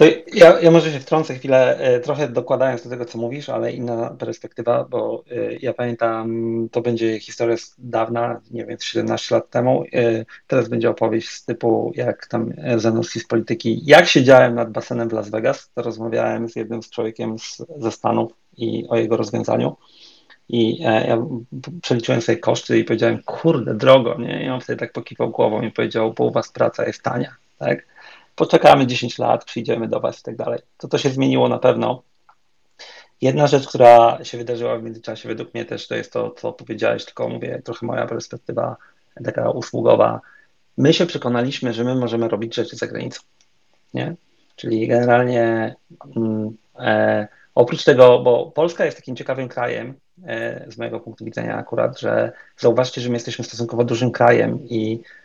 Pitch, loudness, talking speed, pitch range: 120 Hz, -19 LUFS, 170 wpm, 115-125 Hz